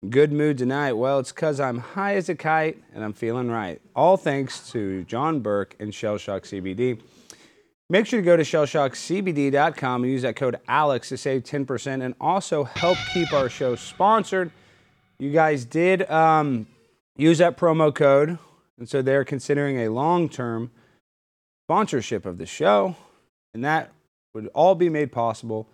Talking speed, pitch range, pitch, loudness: 165 wpm, 115-160 Hz, 140 Hz, -23 LUFS